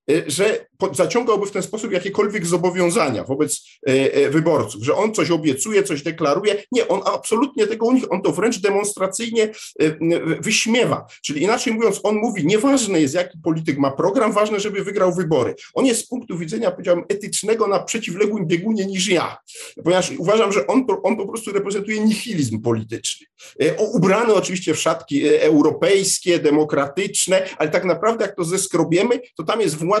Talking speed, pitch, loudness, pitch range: 170 wpm, 190 Hz, -19 LUFS, 165-215 Hz